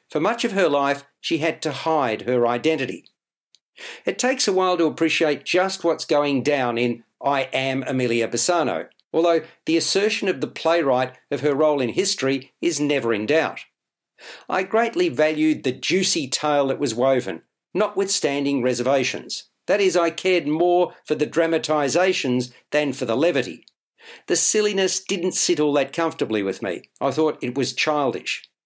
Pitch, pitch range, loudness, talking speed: 155 Hz, 135-180 Hz, -21 LUFS, 165 wpm